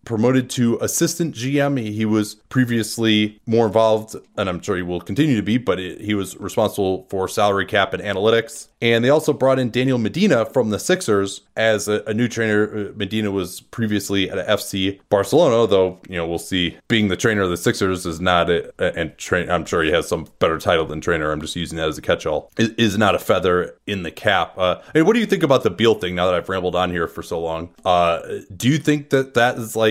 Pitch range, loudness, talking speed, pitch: 95-120 Hz, -19 LUFS, 240 wpm, 105 Hz